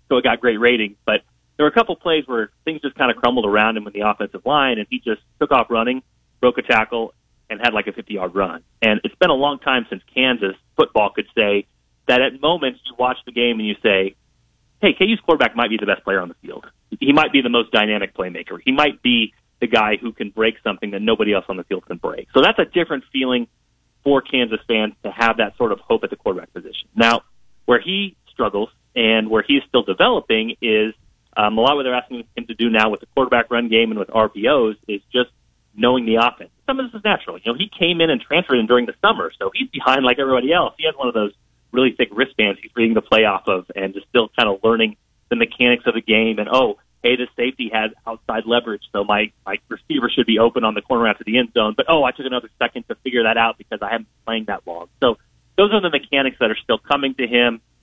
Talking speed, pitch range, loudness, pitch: 250 wpm, 110-130 Hz, -18 LUFS, 115 Hz